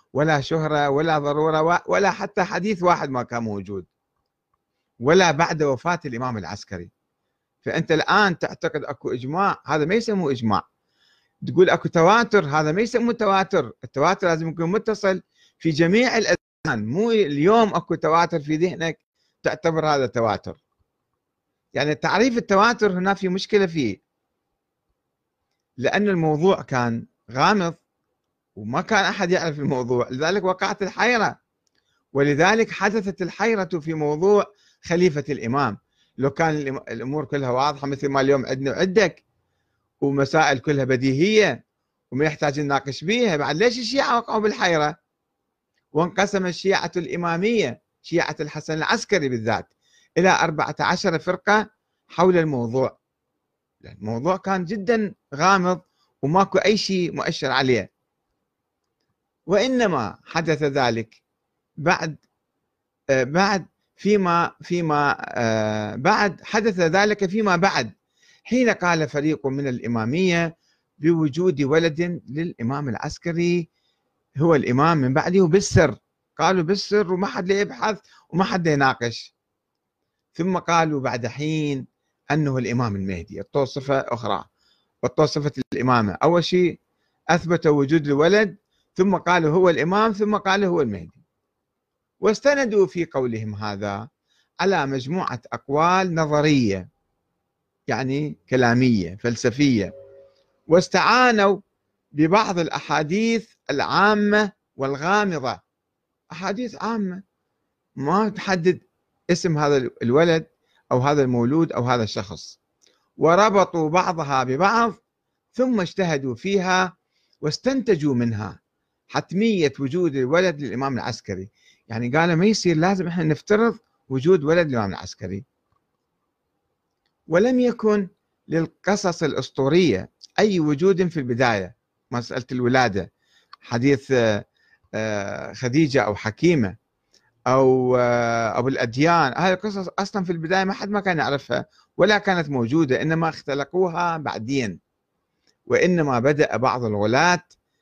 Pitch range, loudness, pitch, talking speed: 135-190 Hz, -21 LUFS, 160 Hz, 110 wpm